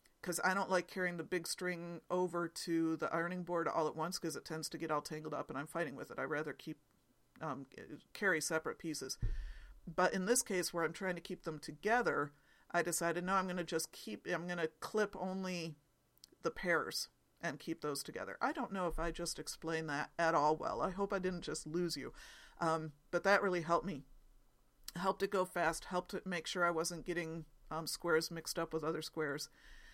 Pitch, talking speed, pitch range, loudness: 170 Hz, 220 wpm, 160-180 Hz, -39 LUFS